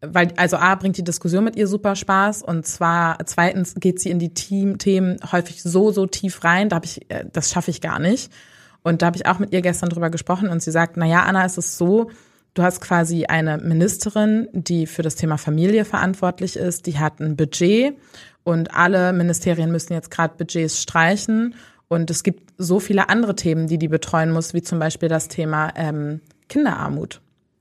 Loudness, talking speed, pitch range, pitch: -20 LUFS, 200 wpm, 165-195 Hz, 175 Hz